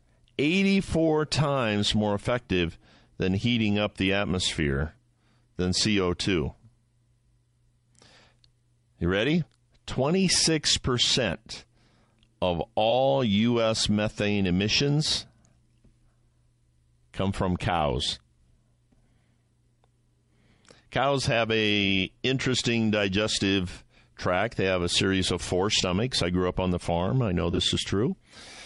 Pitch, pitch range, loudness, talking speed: 110 Hz, 95-120 Hz, -25 LUFS, 95 wpm